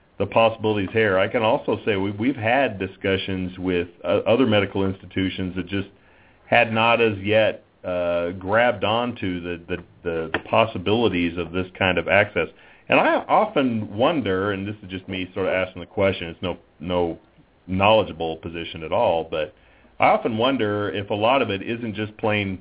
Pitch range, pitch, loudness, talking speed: 90-105 Hz, 95 Hz, -22 LUFS, 180 wpm